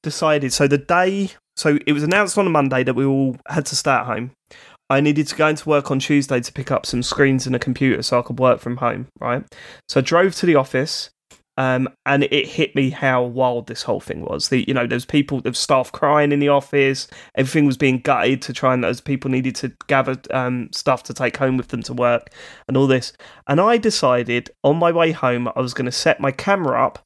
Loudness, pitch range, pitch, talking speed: -19 LUFS, 130-150 Hz, 135 Hz, 240 wpm